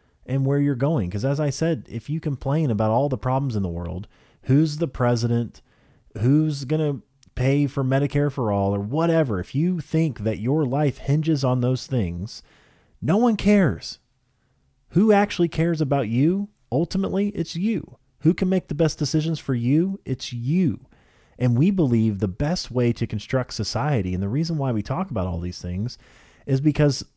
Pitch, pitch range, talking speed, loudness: 140 Hz, 120-160 Hz, 185 wpm, -23 LUFS